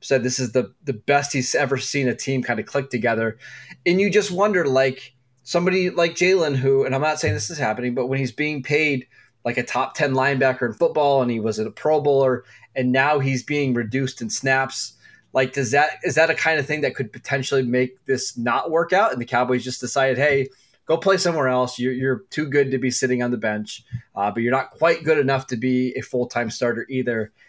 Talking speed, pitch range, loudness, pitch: 235 wpm, 125-145 Hz, -21 LUFS, 130 Hz